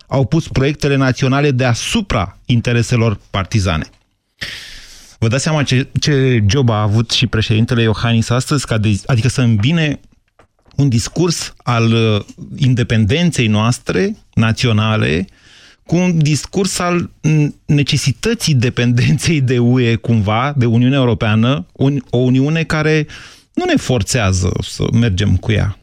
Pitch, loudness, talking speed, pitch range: 125 Hz, -15 LUFS, 125 wpm, 115-145 Hz